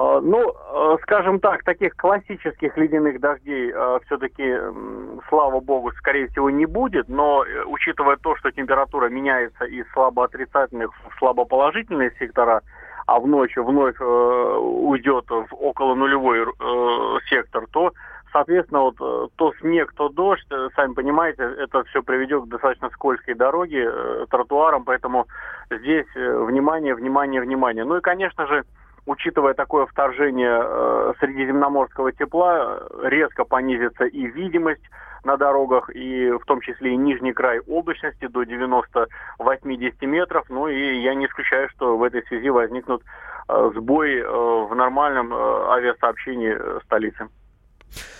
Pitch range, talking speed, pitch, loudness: 125-145 Hz, 130 wpm, 135 Hz, -21 LUFS